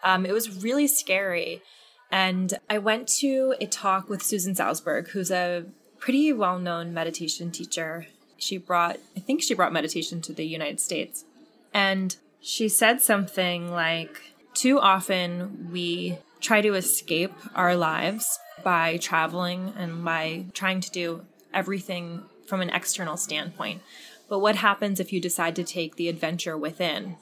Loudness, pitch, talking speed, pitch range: -25 LUFS, 185 Hz, 150 wpm, 170-205 Hz